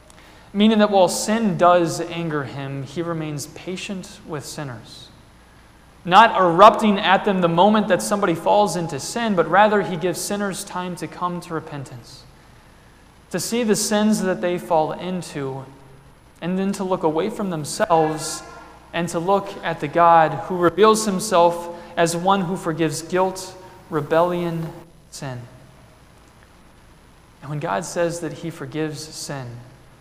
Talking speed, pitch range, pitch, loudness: 145 wpm, 155-185 Hz, 170 Hz, -20 LUFS